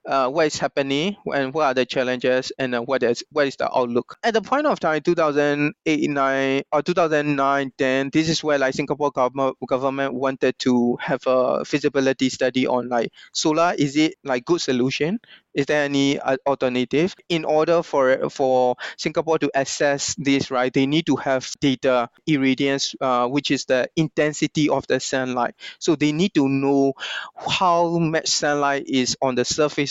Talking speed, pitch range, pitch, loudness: 175 wpm, 130-155 Hz, 140 Hz, -21 LUFS